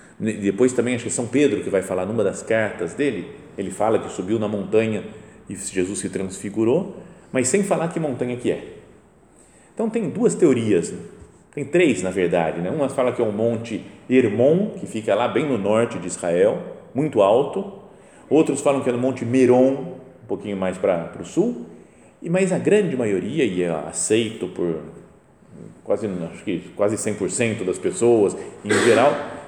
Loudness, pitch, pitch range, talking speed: -21 LUFS, 125 Hz, 110-155 Hz, 180 wpm